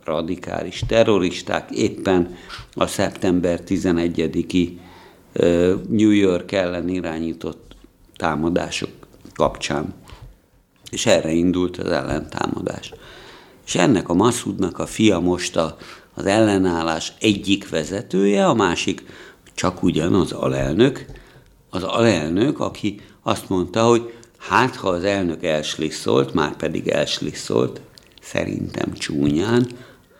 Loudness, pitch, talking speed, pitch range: -20 LUFS, 90 Hz, 100 wpm, 85-100 Hz